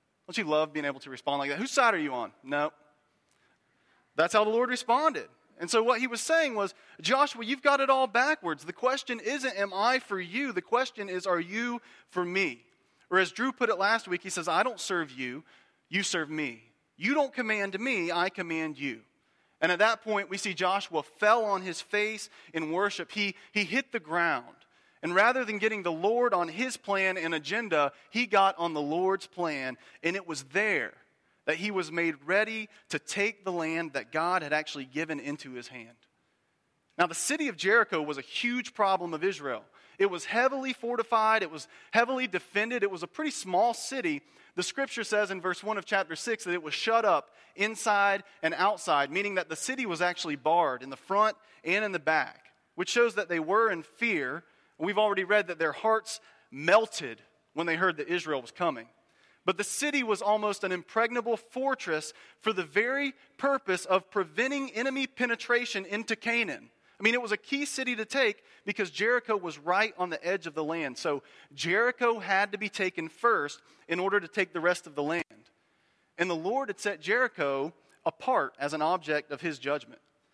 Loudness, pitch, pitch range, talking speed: -29 LUFS, 200 Hz, 170-235 Hz, 200 wpm